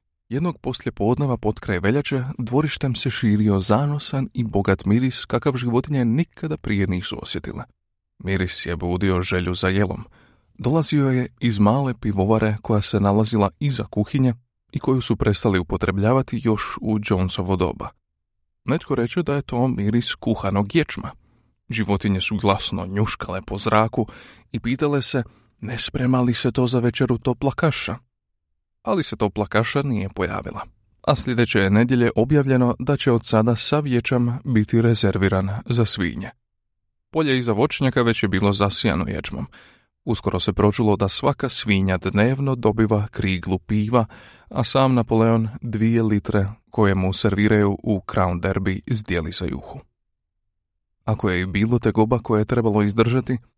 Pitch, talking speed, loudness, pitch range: 110 Hz, 150 wpm, -21 LUFS, 100-125 Hz